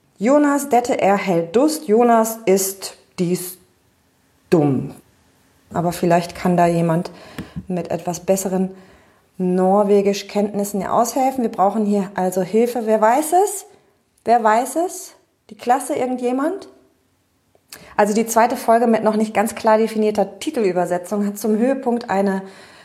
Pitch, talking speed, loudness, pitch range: 210 Hz, 130 wpm, -18 LUFS, 185-240 Hz